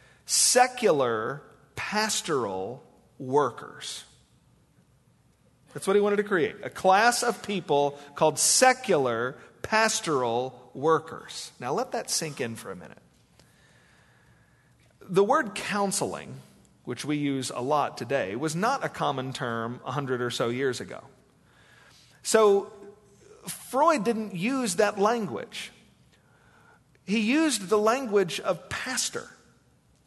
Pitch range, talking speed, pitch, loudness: 140-220 Hz, 110 wpm, 195 Hz, -26 LUFS